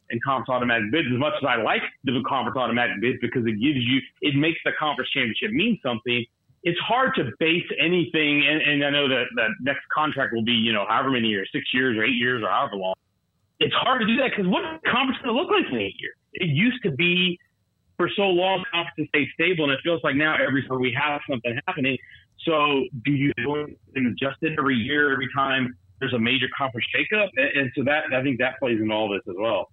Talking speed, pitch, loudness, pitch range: 240 wpm, 135 Hz, -23 LUFS, 120-160 Hz